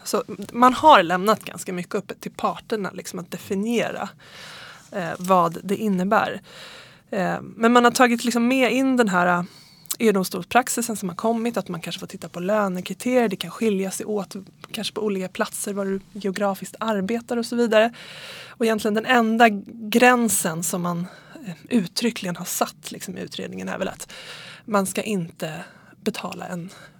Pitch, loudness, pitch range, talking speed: 205 Hz, -22 LUFS, 185-230 Hz, 170 wpm